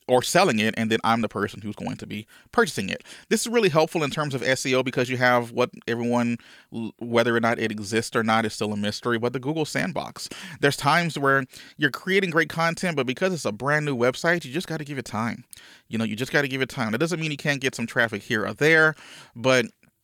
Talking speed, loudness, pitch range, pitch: 245 wpm, -24 LUFS, 115-155 Hz, 130 Hz